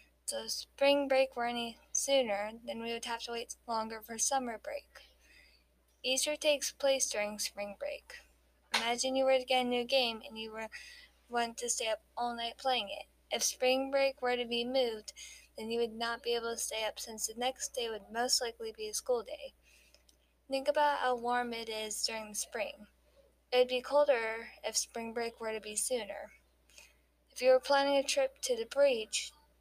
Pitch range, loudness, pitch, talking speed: 225-270 Hz, -33 LUFS, 240 Hz, 200 wpm